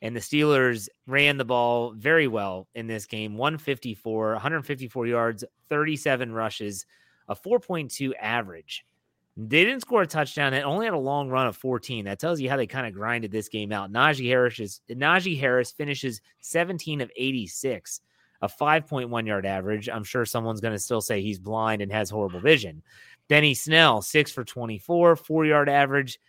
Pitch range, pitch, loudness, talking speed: 110-145 Hz, 125 Hz, -25 LUFS, 175 wpm